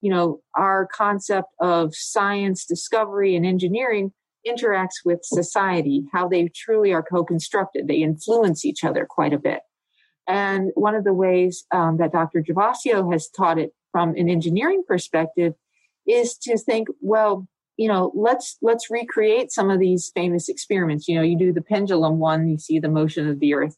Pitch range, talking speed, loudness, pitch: 170-210 Hz, 170 wpm, -21 LUFS, 185 Hz